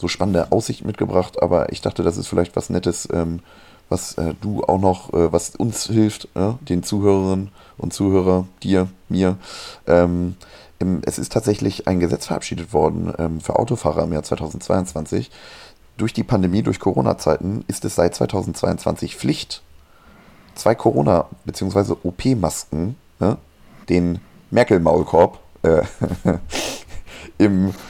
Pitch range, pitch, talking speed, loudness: 85-100 Hz, 95 Hz, 120 wpm, -20 LUFS